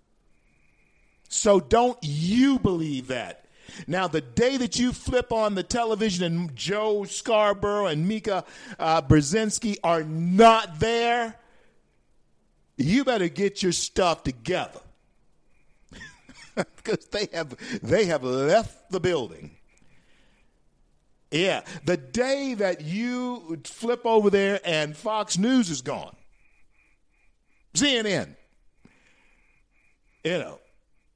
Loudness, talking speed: -24 LUFS, 105 wpm